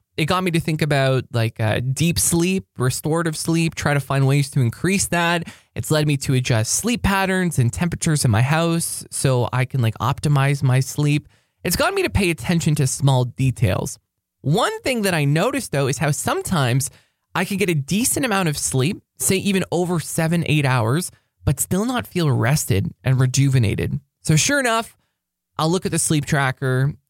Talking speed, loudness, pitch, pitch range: 190 wpm, -20 LUFS, 150 Hz, 130-175 Hz